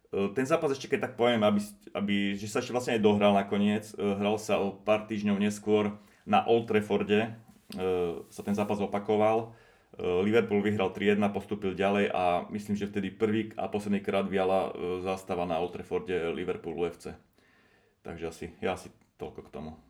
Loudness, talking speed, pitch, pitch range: -29 LUFS, 170 wpm, 105 Hz, 100-105 Hz